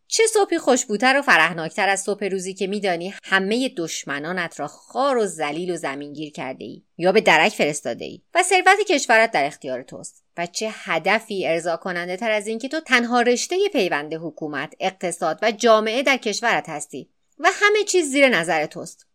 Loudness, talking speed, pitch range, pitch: -20 LUFS, 175 wpm, 165-255 Hz, 200 Hz